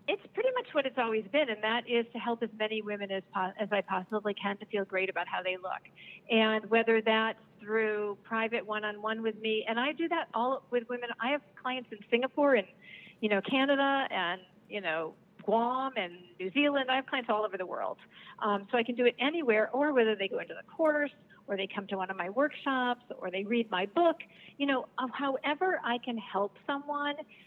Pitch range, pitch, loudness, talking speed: 205-265 Hz, 225 Hz, -31 LUFS, 215 wpm